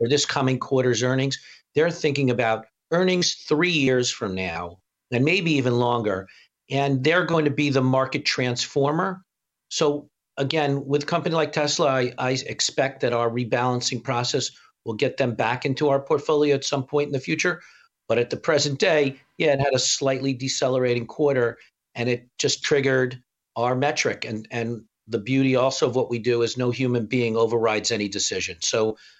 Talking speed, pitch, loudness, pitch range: 180 wpm, 130 Hz, -23 LUFS, 120-145 Hz